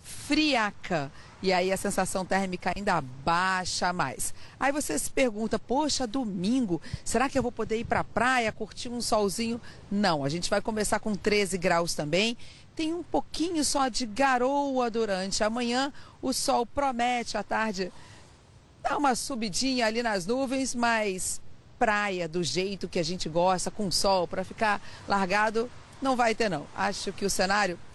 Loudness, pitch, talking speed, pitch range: -28 LUFS, 215 Hz, 165 wpm, 190-245 Hz